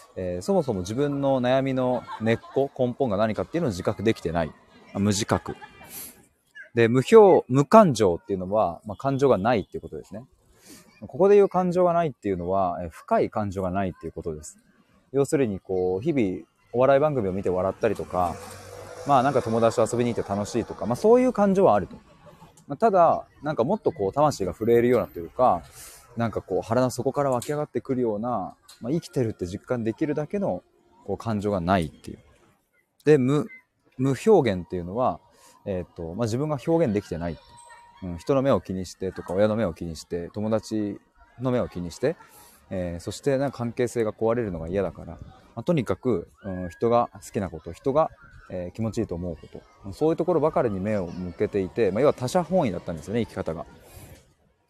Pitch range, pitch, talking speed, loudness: 95-135 Hz, 115 Hz, 395 characters per minute, -24 LUFS